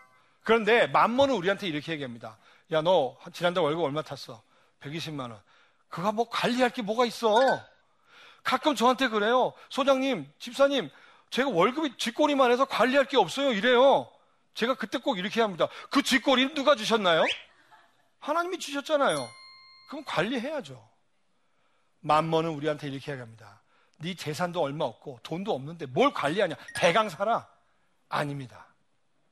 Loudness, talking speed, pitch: -26 LUFS, 320 characters per minute, 225 Hz